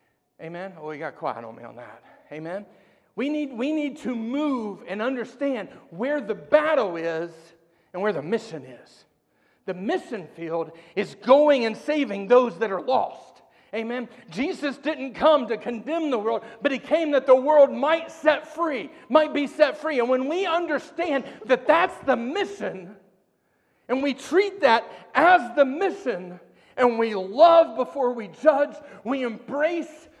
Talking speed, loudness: 165 wpm, -23 LUFS